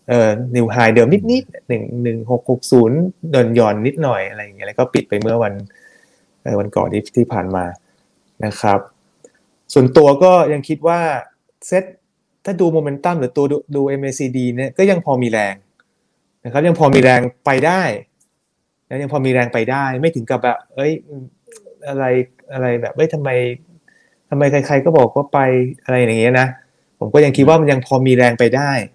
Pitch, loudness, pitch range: 130 Hz, -15 LUFS, 120-150 Hz